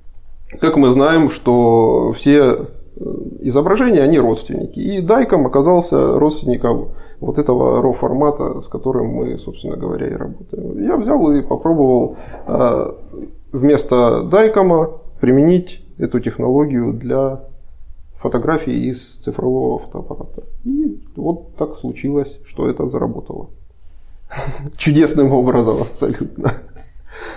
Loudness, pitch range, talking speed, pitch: -15 LUFS, 115-160 Hz, 105 wpm, 135 Hz